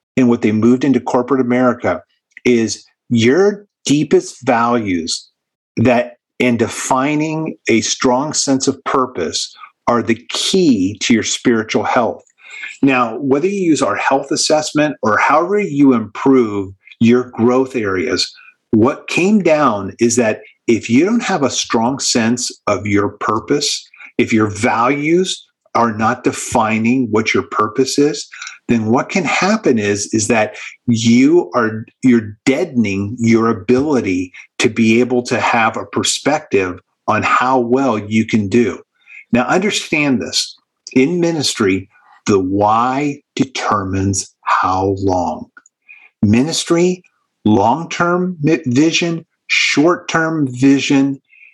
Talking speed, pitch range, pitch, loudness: 125 wpm, 110-155 Hz, 125 Hz, -15 LUFS